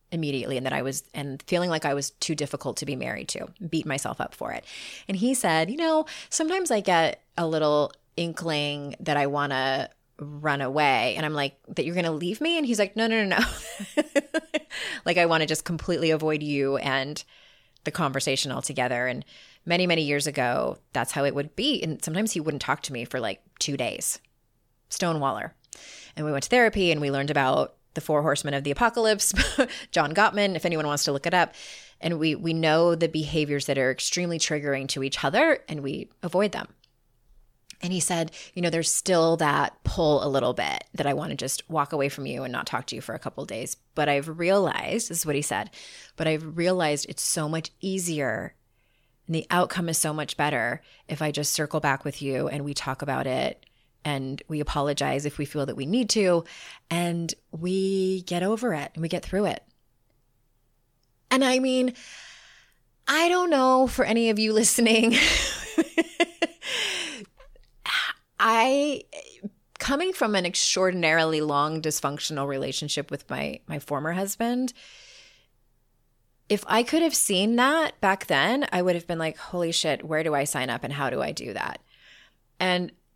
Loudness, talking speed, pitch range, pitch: -25 LUFS, 190 wpm, 145-200 Hz, 160 Hz